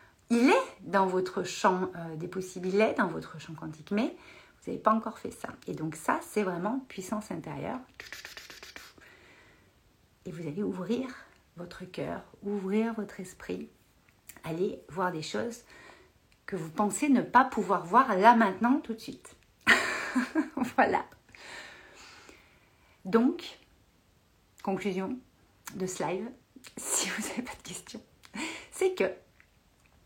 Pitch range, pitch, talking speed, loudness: 185-240 Hz, 205 Hz, 135 wpm, -30 LUFS